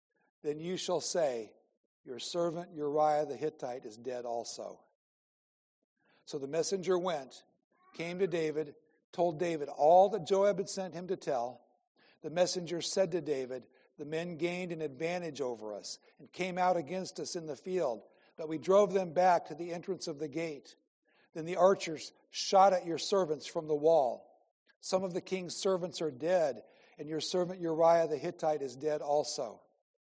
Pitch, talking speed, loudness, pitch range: 170 Hz, 170 wpm, -33 LUFS, 155-185 Hz